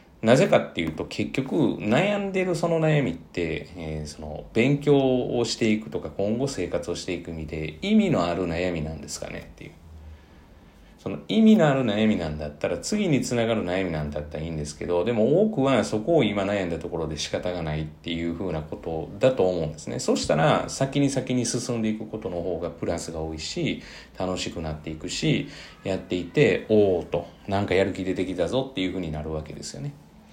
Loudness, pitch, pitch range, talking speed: -25 LUFS, 90 Hz, 80-125 Hz, 355 characters per minute